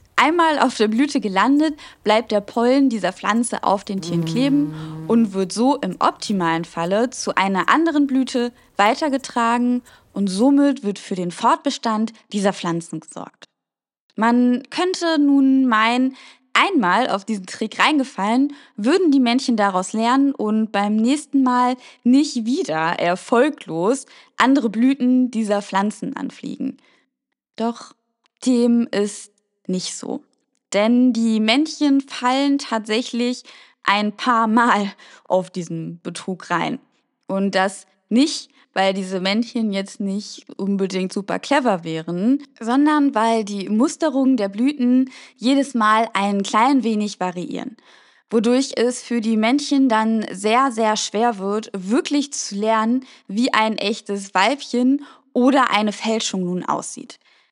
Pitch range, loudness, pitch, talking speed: 200-265 Hz, -19 LUFS, 230 Hz, 130 wpm